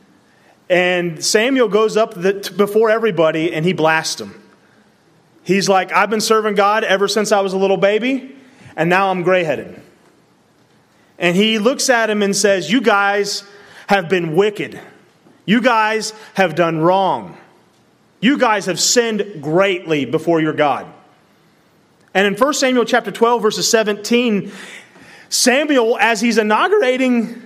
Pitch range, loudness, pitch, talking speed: 185-230 Hz, -15 LUFS, 205 Hz, 140 wpm